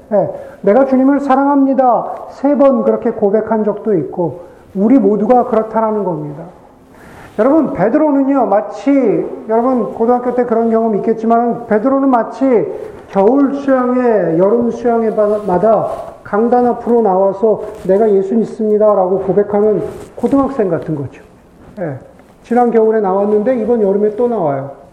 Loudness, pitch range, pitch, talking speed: -13 LUFS, 205-250 Hz, 225 Hz, 310 characters per minute